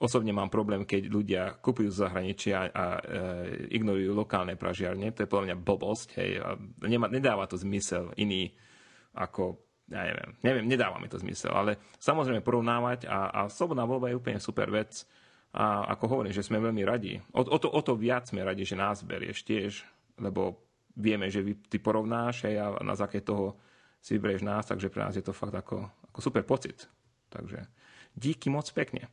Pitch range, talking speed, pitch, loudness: 100-120 Hz, 185 wpm, 105 Hz, -31 LUFS